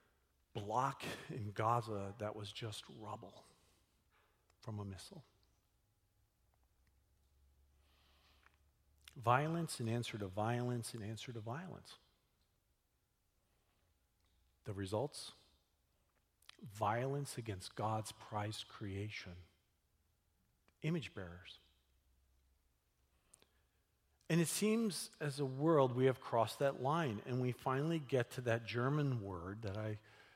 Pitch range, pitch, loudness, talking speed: 90-125 Hz, 105 Hz, -40 LUFS, 95 wpm